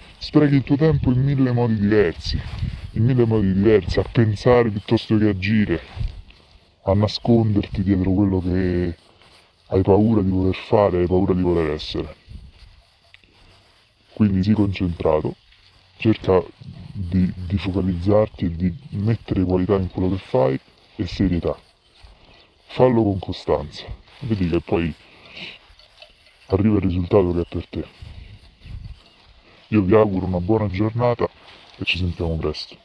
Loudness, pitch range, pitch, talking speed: -20 LUFS, 90-110 Hz, 95 Hz, 130 wpm